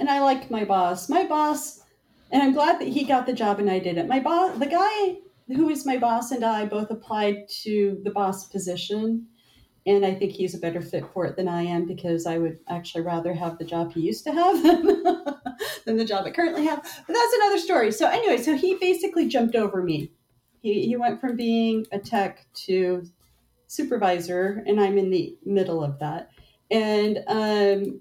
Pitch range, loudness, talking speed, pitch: 185-285 Hz, -24 LUFS, 205 wpm, 215 Hz